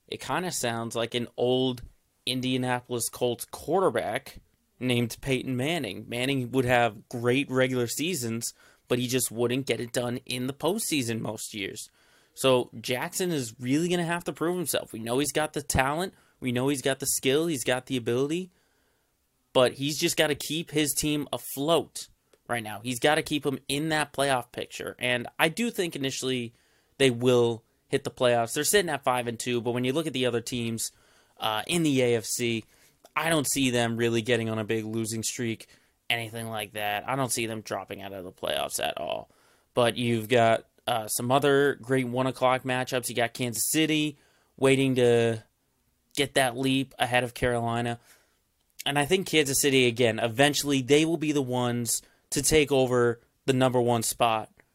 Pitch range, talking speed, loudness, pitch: 120-140 Hz, 185 wpm, -27 LUFS, 125 Hz